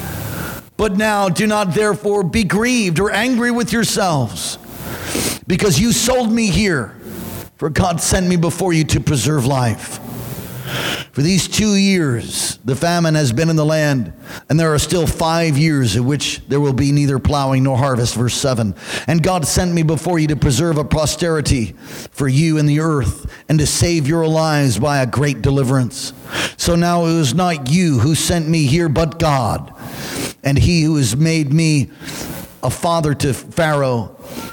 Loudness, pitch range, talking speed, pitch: -16 LUFS, 135-175 Hz, 170 wpm, 155 Hz